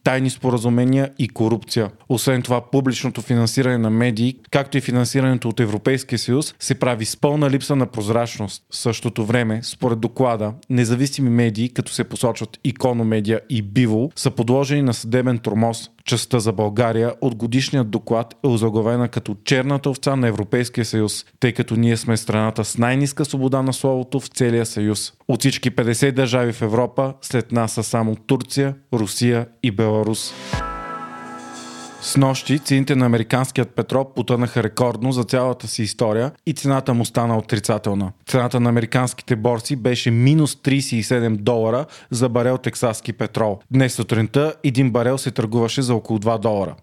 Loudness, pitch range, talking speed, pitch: -20 LUFS, 115-130 Hz, 155 wpm, 120 Hz